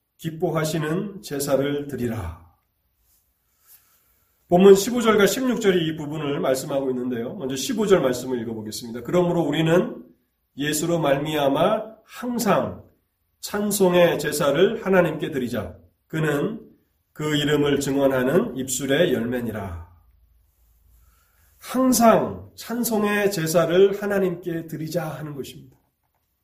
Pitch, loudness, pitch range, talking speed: 145 Hz, -22 LUFS, 115-180 Hz, 245 characters per minute